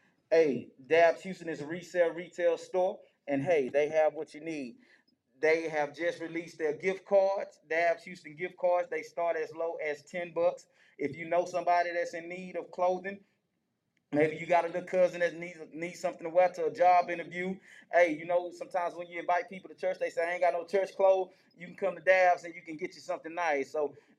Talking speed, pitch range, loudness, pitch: 220 wpm, 165-180 Hz, -31 LUFS, 175 Hz